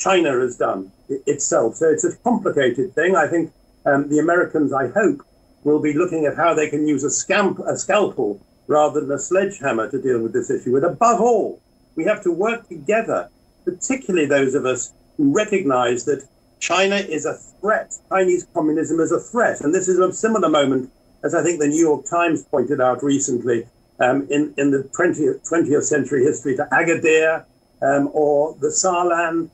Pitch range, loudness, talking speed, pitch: 145-200 Hz, -19 LUFS, 185 wpm, 165 Hz